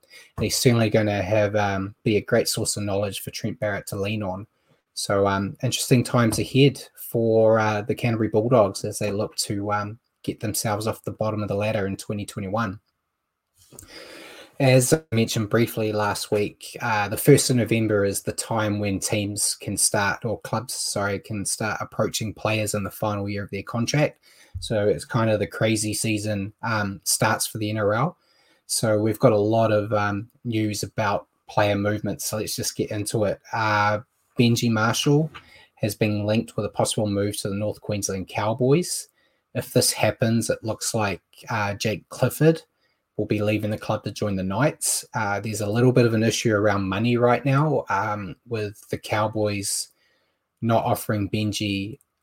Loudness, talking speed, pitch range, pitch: -23 LUFS, 180 wpm, 105-115 Hz, 105 Hz